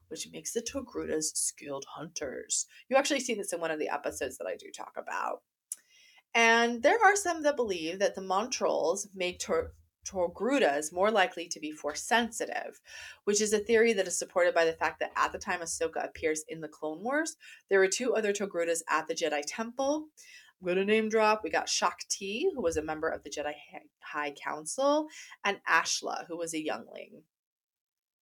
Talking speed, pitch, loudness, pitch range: 190 wpm, 195 Hz, -30 LUFS, 160-255 Hz